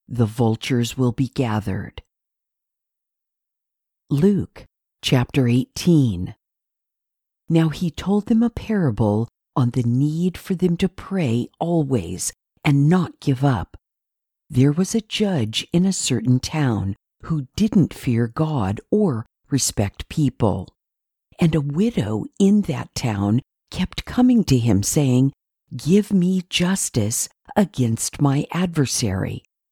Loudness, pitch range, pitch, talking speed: -21 LUFS, 120-180 Hz, 140 Hz, 115 wpm